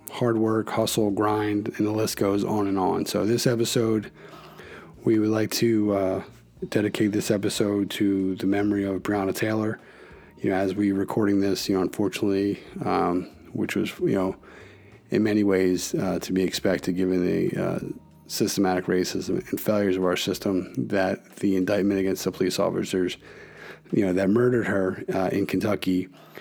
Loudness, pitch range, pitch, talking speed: -25 LUFS, 95-105 Hz, 100 Hz, 170 wpm